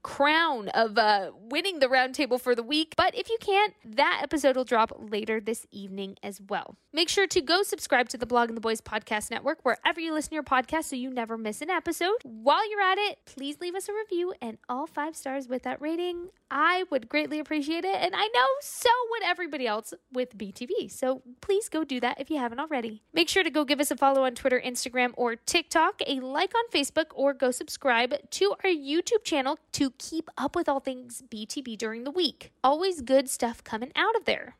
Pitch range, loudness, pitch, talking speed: 245-340 Hz, -27 LUFS, 285 Hz, 220 wpm